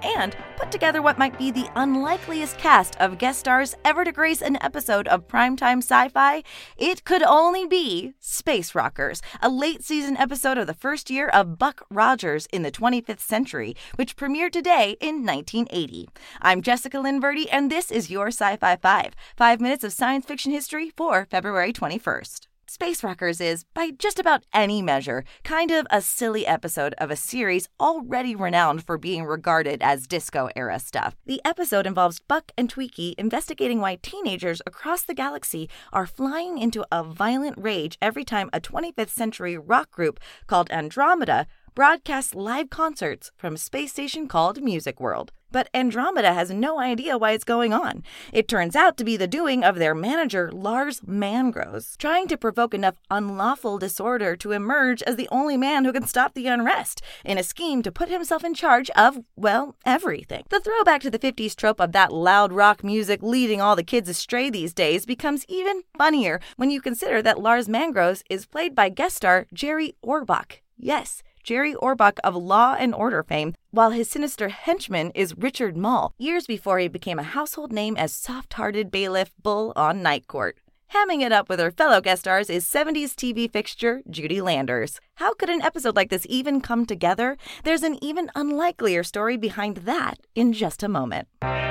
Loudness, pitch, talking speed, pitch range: -23 LUFS, 240 Hz, 180 wpm, 195-290 Hz